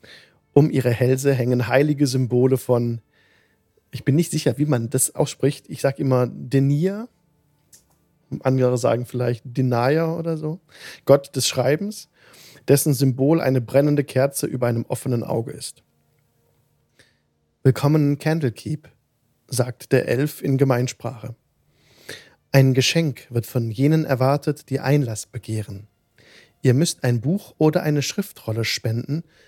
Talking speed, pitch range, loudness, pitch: 125 wpm, 125-150 Hz, -21 LUFS, 135 Hz